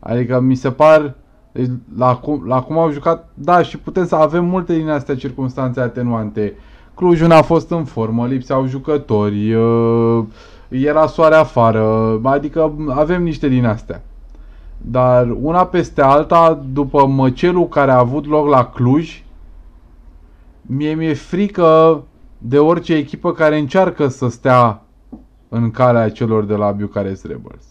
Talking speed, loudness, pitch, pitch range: 140 wpm, -15 LUFS, 135 Hz, 115-155 Hz